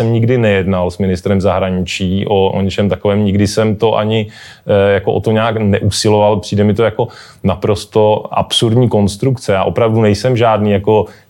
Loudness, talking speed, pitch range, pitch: -13 LUFS, 170 wpm, 100-110 Hz, 105 Hz